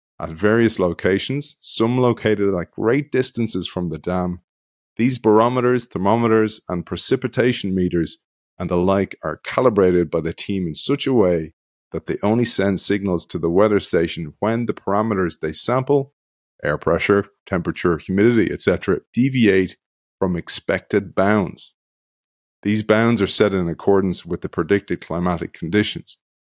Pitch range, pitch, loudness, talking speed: 90-115 Hz, 100 Hz, -19 LUFS, 140 wpm